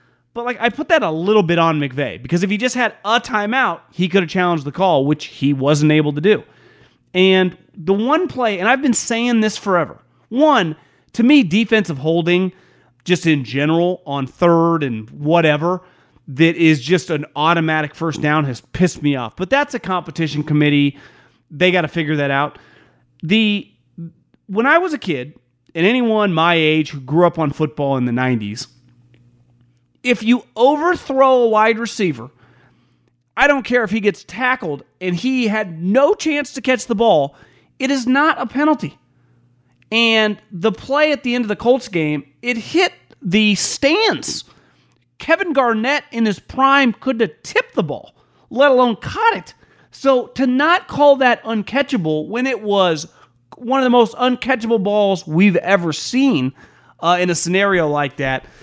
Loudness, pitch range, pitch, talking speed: -17 LUFS, 150-245 Hz, 185 Hz, 175 wpm